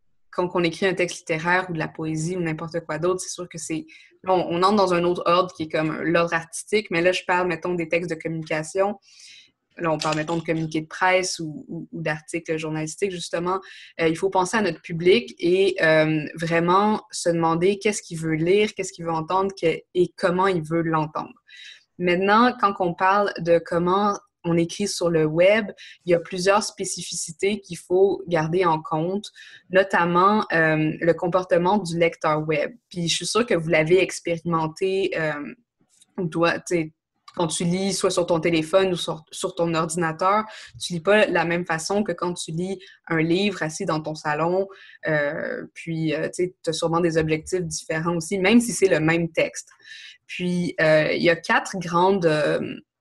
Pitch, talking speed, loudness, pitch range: 175 Hz, 190 wpm, -23 LUFS, 165-190 Hz